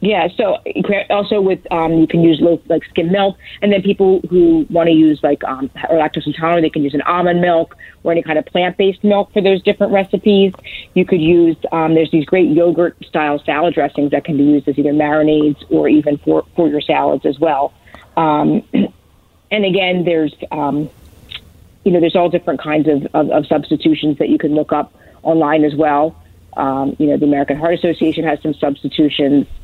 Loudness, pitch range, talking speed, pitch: -14 LUFS, 150-175 Hz, 200 wpm, 160 Hz